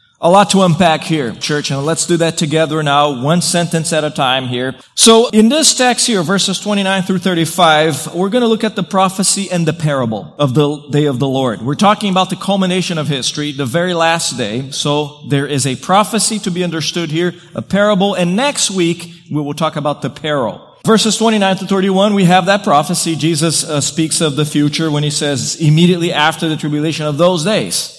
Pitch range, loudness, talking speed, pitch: 150-190 Hz, -13 LUFS, 210 wpm, 165 Hz